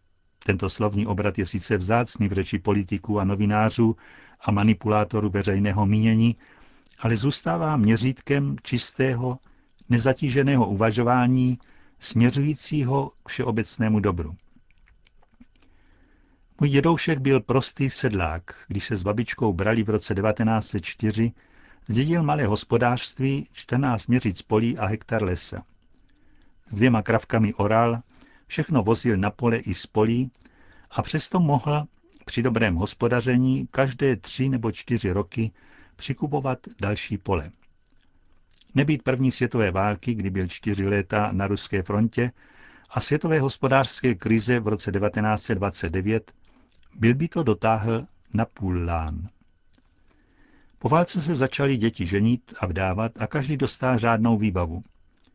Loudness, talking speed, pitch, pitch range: -24 LUFS, 120 wpm, 115 Hz, 105-130 Hz